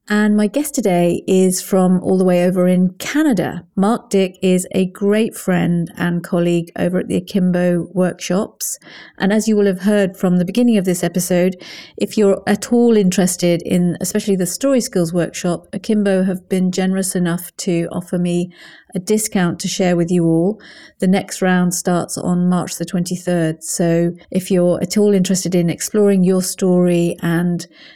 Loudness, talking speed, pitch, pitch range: -17 LUFS, 175 wpm, 185 Hz, 175-195 Hz